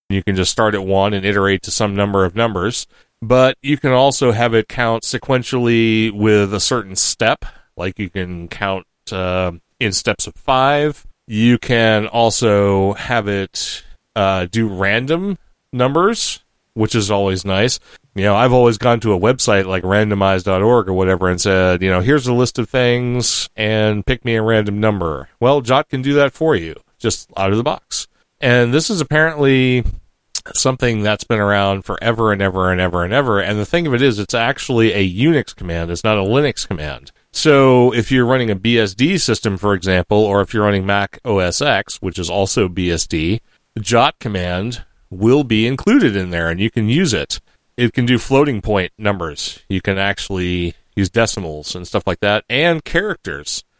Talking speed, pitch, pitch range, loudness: 185 wpm, 110 Hz, 95-125 Hz, -16 LUFS